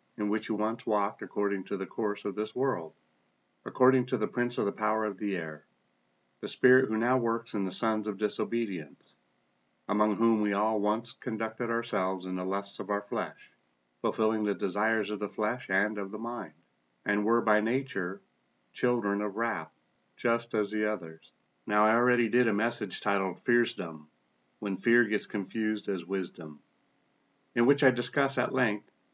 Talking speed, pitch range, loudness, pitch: 175 wpm, 95-115 Hz, -30 LUFS, 105 Hz